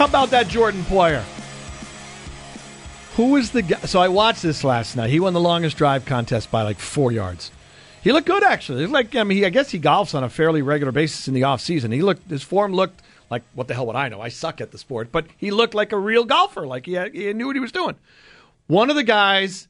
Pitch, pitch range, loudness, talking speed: 170 Hz, 130-215 Hz, -20 LUFS, 250 wpm